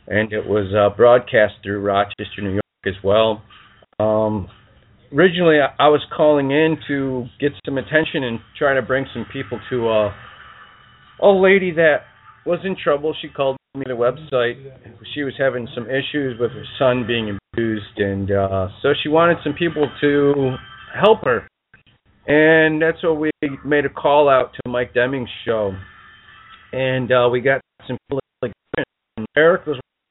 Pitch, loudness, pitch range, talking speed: 130 Hz, -18 LUFS, 110-150 Hz, 160 wpm